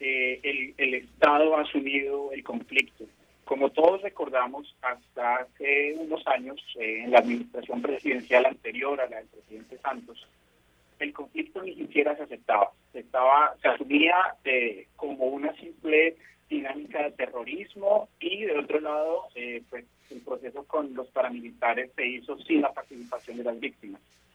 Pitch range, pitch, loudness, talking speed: 125-160 Hz, 140 Hz, -27 LUFS, 155 wpm